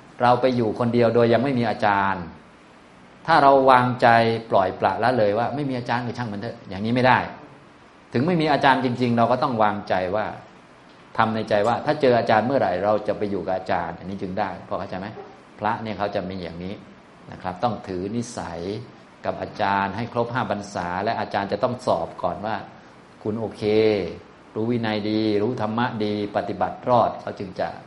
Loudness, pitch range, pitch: -22 LUFS, 100-120 Hz, 110 Hz